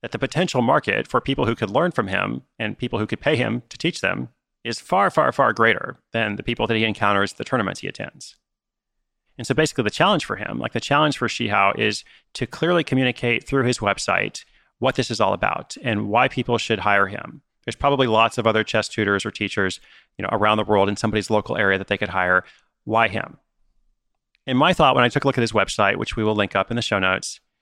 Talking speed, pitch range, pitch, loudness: 240 wpm, 100-125 Hz, 110 Hz, -21 LUFS